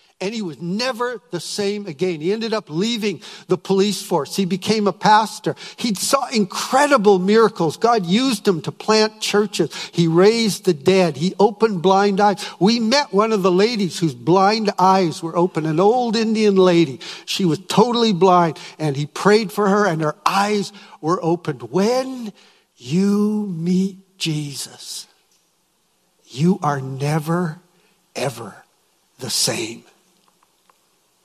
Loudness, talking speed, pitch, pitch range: -18 LUFS, 145 wpm, 195 Hz, 175-210 Hz